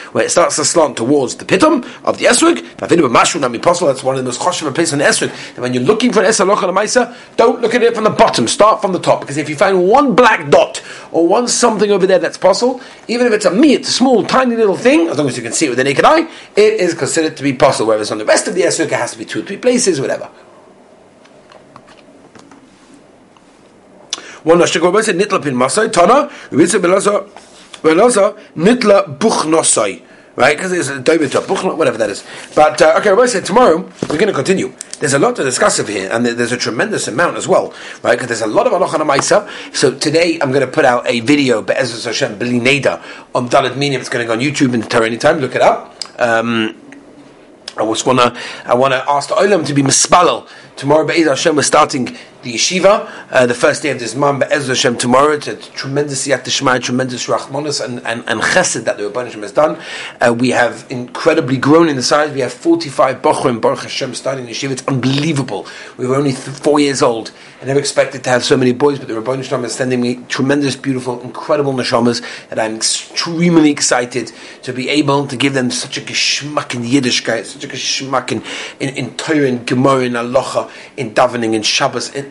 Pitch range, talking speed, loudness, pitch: 125-185 Hz, 215 wpm, -13 LUFS, 140 Hz